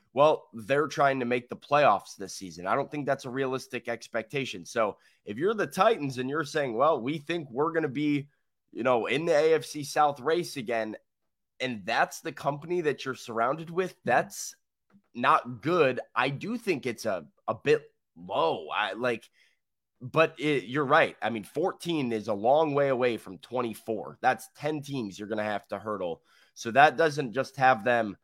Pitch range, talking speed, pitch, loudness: 120-155 Hz, 190 wpm, 135 Hz, -28 LUFS